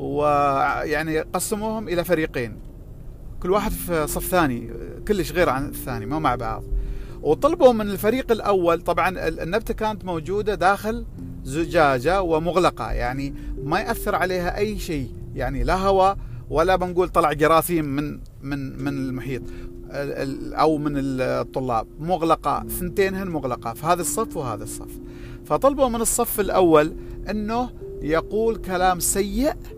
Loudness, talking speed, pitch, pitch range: -22 LUFS, 130 wpm, 165 Hz, 135-195 Hz